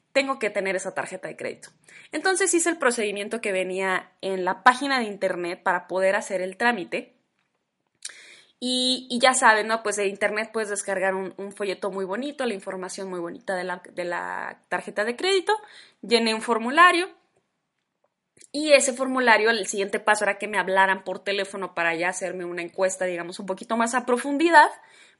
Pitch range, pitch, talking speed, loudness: 190-255 Hz, 205 Hz, 180 wpm, -23 LUFS